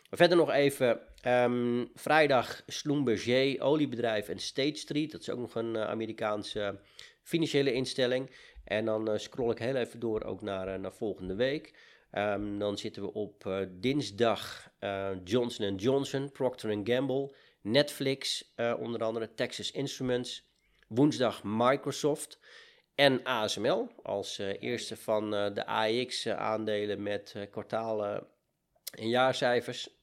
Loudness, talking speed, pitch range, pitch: -31 LUFS, 140 wpm, 105-135 Hz, 120 Hz